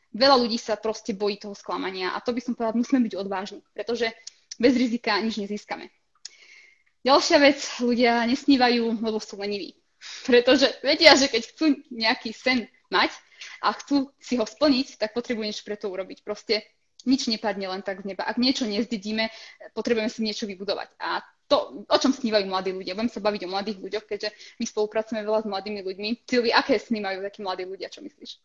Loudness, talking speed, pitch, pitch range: -24 LUFS, 185 wpm, 225 Hz, 210-245 Hz